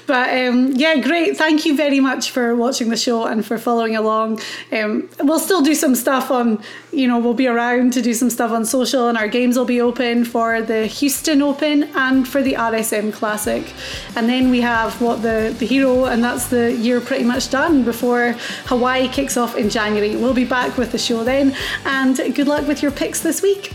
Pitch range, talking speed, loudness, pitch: 235-275 Hz, 215 wpm, -17 LUFS, 250 Hz